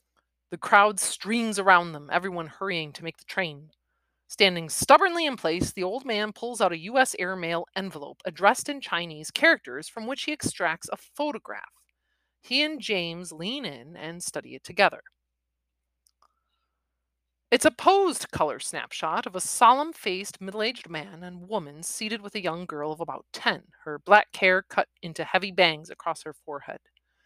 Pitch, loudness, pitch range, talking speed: 185 Hz, -25 LUFS, 160-225 Hz, 165 wpm